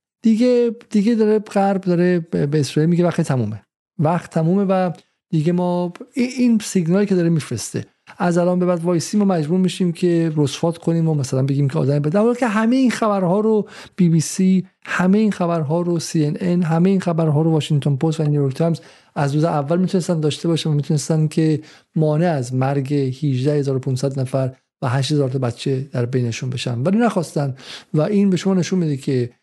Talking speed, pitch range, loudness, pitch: 185 wpm, 145-185 Hz, -19 LUFS, 165 Hz